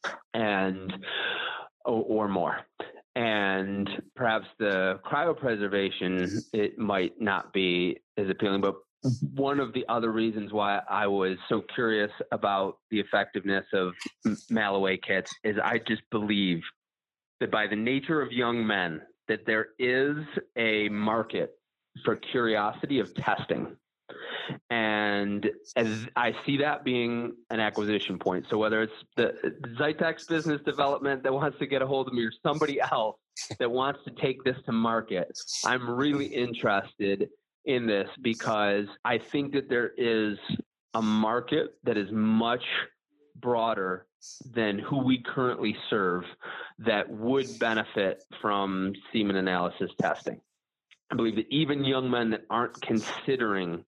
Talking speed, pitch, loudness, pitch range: 135 wpm, 110 Hz, -29 LUFS, 100-130 Hz